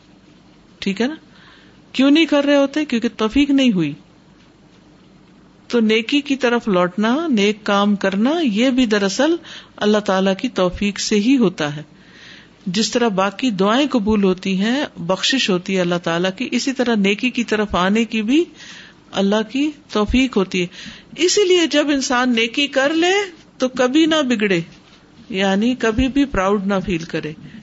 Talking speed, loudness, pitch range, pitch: 160 wpm, -18 LUFS, 195-270 Hz, 225 Hz